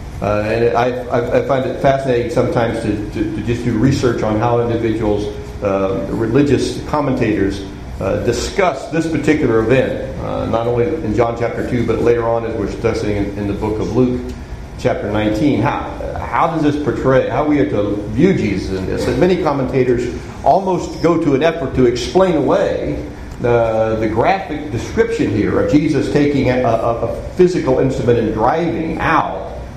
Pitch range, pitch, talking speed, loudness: 110-145 Hz, 120 Hz, 170 wpm, -16 LUFS